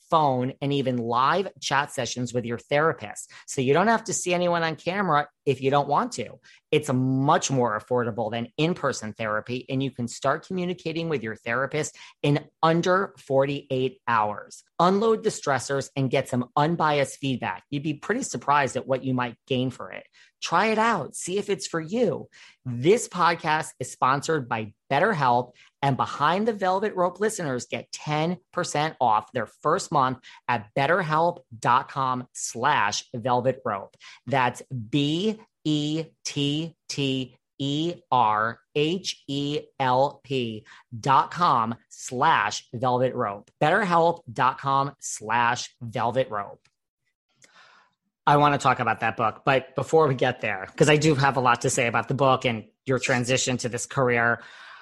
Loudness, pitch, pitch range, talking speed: -25 LUFS, 140 Hz, 125-160 Hz, 155 wpm